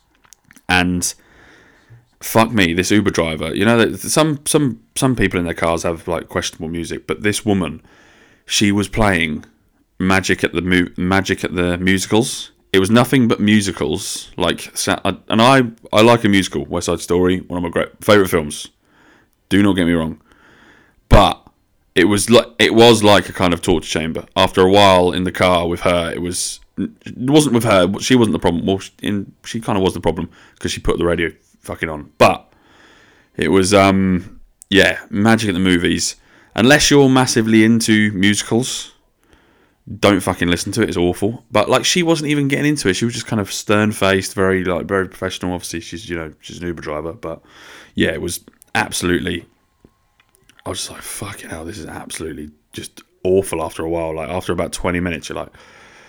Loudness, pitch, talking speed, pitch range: -16 LUFS, 95 Hz, 190 wpm, 85-110 Hz